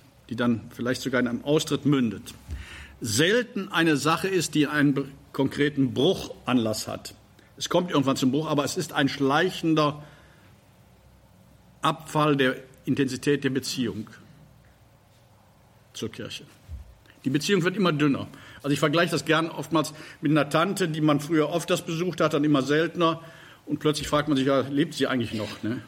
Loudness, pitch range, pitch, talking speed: -25 LUFS, 125-155 Hz, 145 Hz, 160 wpm